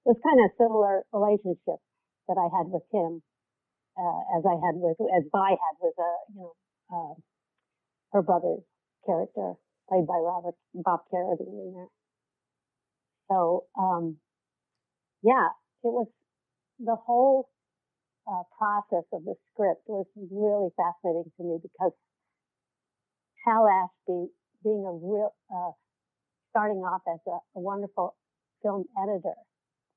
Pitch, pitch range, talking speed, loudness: 190 Hz, 175-210 Hz, 135 wpm, -28 LUFS